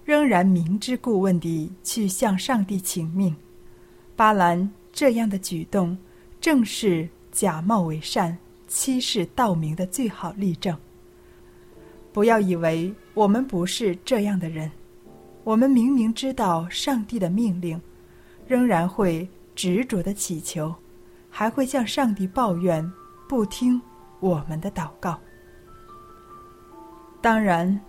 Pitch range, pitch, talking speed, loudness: 165-220 Hz, 185 Hz, 175 characters per minute, -23 LUFS